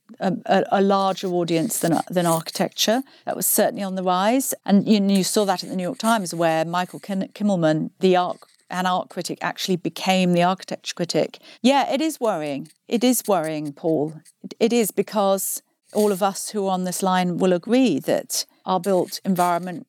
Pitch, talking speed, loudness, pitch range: 190 Hz, 190 wpm, -22 LUFS, 175-215 Hz